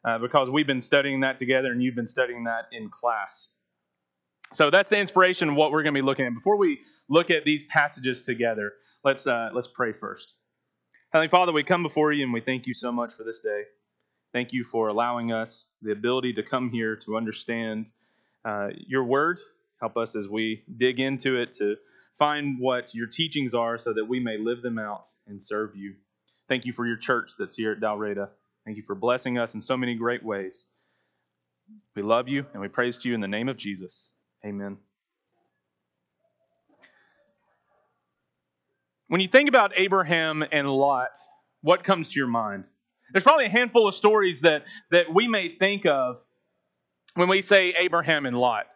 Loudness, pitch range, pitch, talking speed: -25 LUFS, 110-155 Hz, 125 Hz, 190 wpm